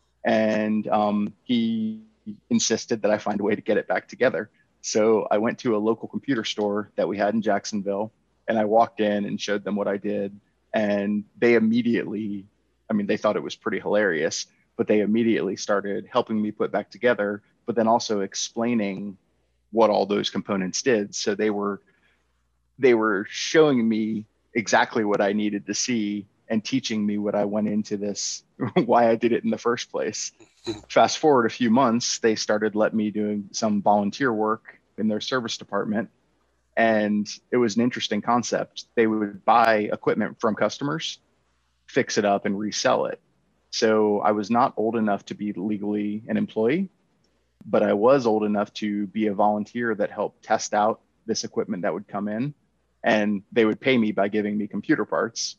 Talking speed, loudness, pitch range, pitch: 185 wpm, -24 LUFS, 100-115 Hz, 105 Hz